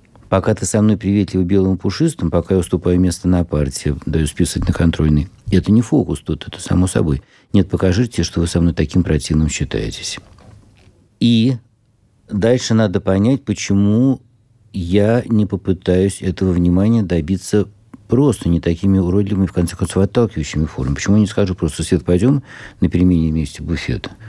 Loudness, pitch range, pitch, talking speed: -17 LUFS, 85-105 Hz, 95 Hz, 160 wpm